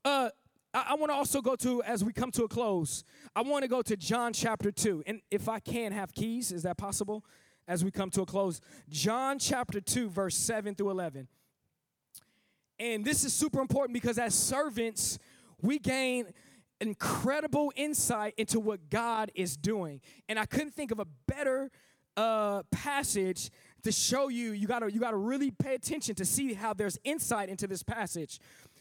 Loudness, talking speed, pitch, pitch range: -32 LUFS, 185 wpm, 220 Hz, 195-255 Hz